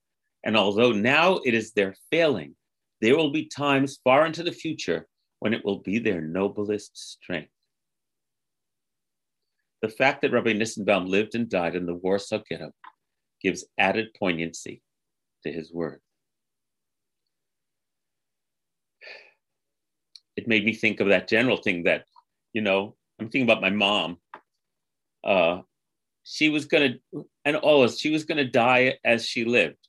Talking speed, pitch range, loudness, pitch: 145 wpm, 95-130 Hz, -24 LUFS, 110 Hz